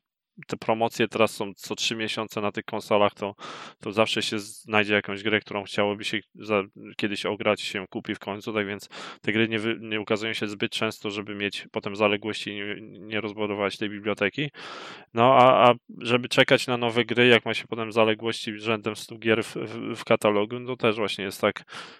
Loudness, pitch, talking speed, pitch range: -25 LUFS, 110 Hz, 200 wpm, 105-115 Hz